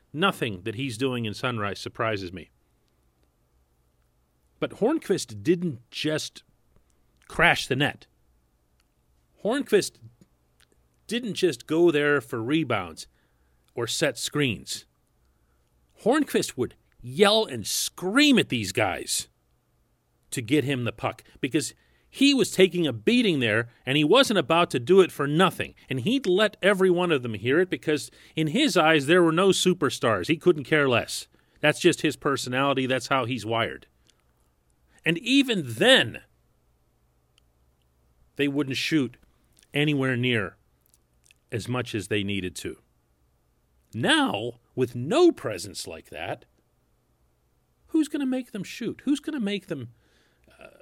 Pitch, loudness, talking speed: 125 Hz, -24 LUFS, 135 wpm